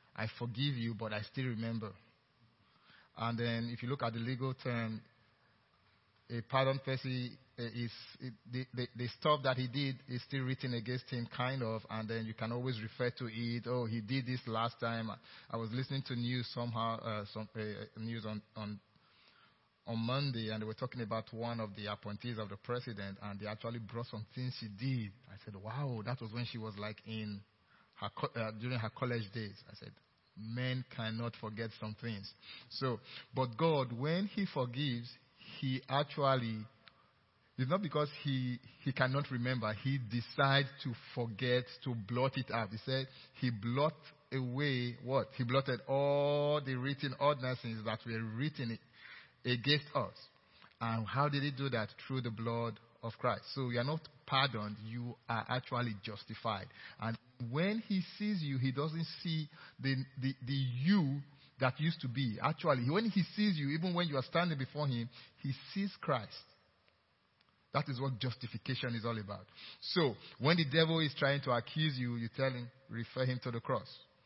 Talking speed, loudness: 180 wpm, -38 LUFS